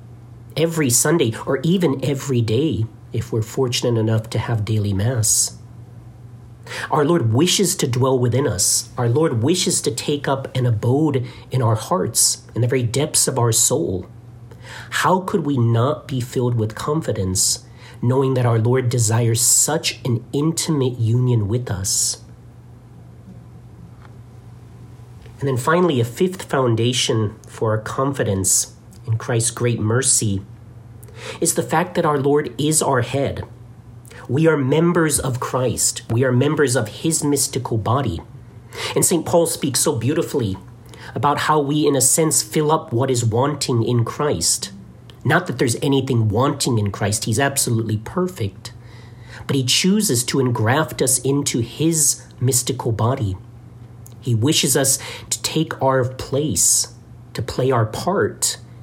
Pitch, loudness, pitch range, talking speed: 120 Hz, -18 LUFS, 115-140 Hz, 145 wpm